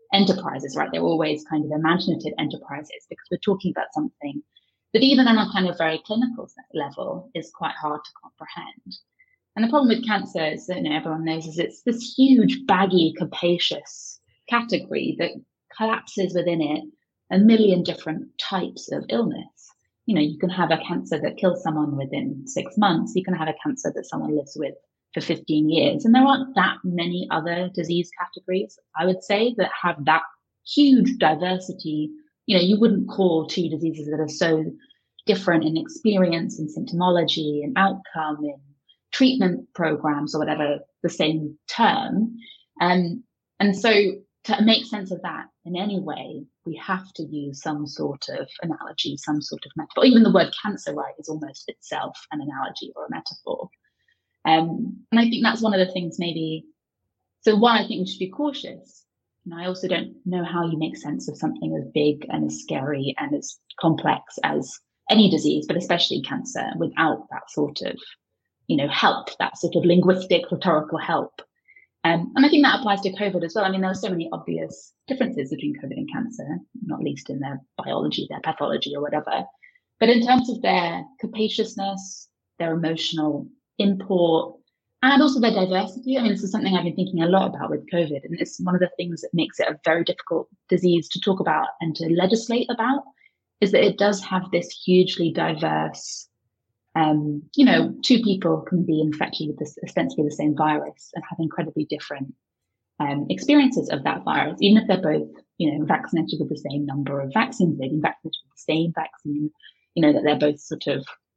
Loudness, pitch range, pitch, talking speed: -23 LUFS, 155-215 Hz, 175 Hz, 185 wpm